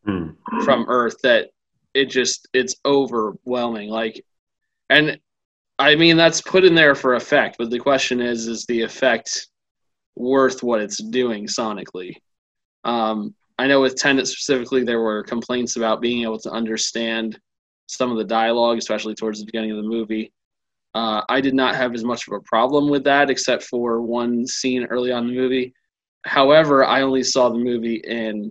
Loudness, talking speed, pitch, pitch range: -19 LUFS, 175 wpm, 120 Hz, 115-130 Hz